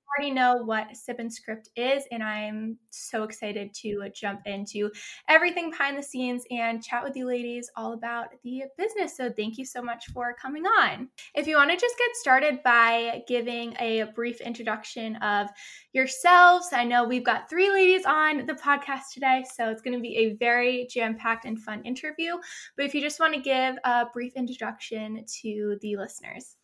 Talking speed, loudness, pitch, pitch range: 190 wpm, -26 LUFS, 245 Hz, 225-280 Hz